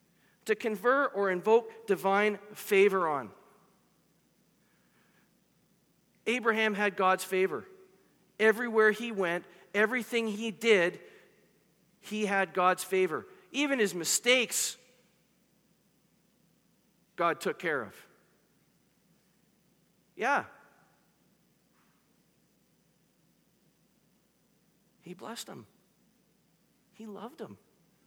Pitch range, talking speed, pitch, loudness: 190-225 Hz, 75 wpm, 210 Hz, -29 LUFS